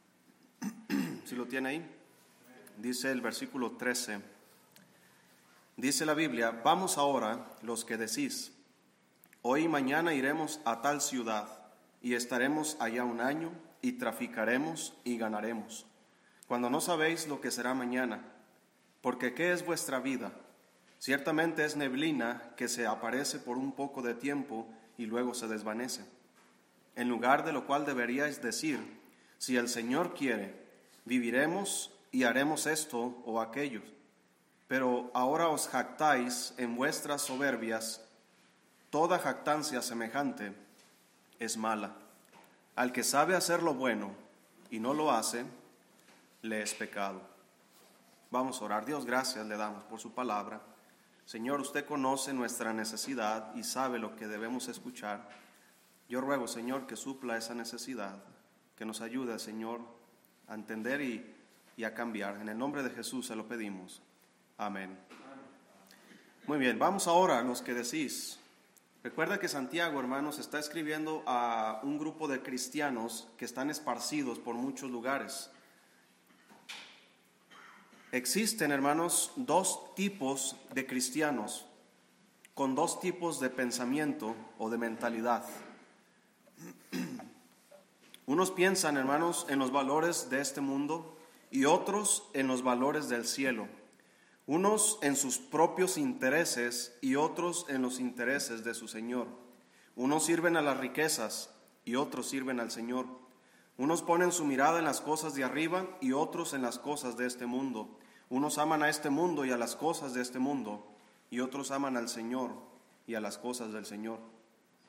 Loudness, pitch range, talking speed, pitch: -34 LUFS, 115-150 Hz, 140 wpm, 130 Hz